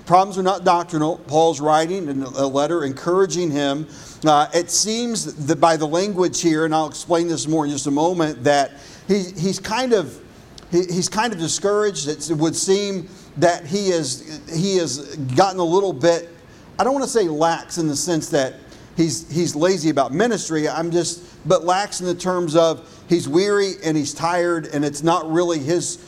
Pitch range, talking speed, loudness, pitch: 155-180 Hz, 195 wpm, -20 LUFS, 165 Hz